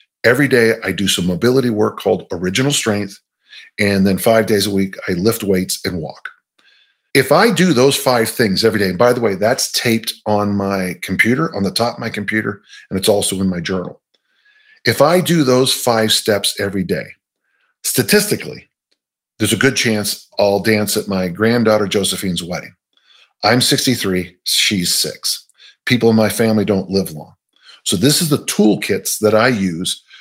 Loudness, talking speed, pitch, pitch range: -15 LUFS, 175 wpm, 110 Hz, 100-125 Hz